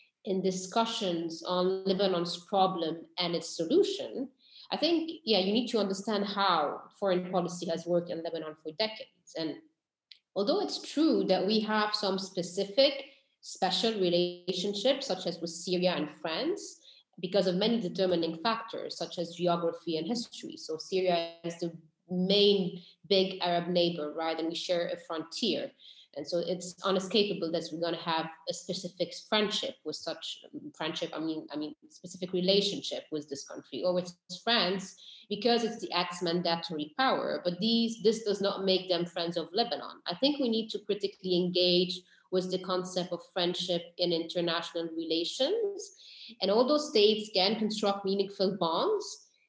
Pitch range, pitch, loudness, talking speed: 175-220 Hz, 185 Hz, -31 LUFS, 160 wpm